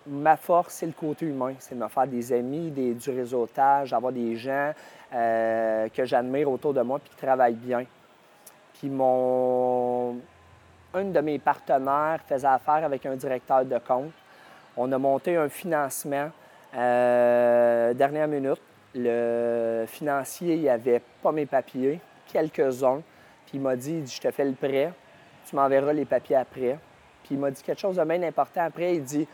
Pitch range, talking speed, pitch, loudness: 125-150 Hz, 175 wpm, 135 Hz, -26 LUFS